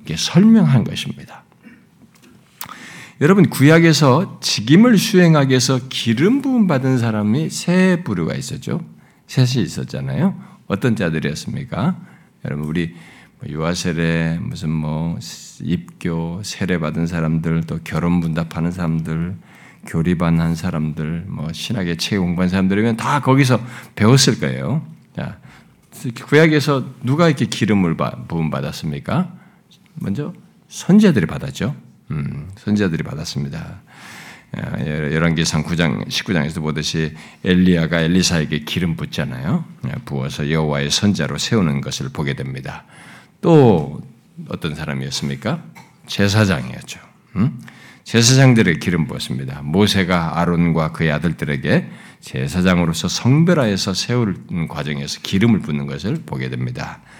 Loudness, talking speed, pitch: -18 LUFS, 290 characters per minute, 90 Hz